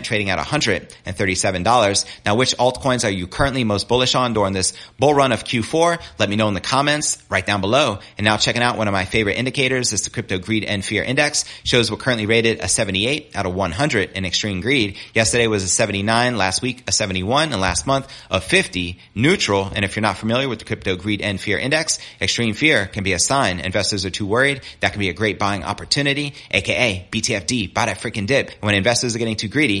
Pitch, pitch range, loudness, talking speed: 110 Hz, 100-125 Hz, -19 LUFS, 220 wpm